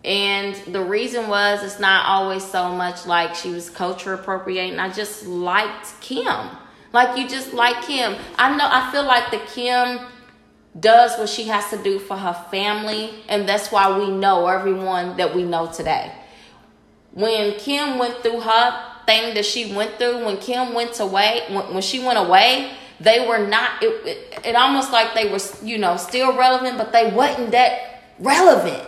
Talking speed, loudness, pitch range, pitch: 180 wpm, -19 LUFS, 195-245 Hz, 215 Hz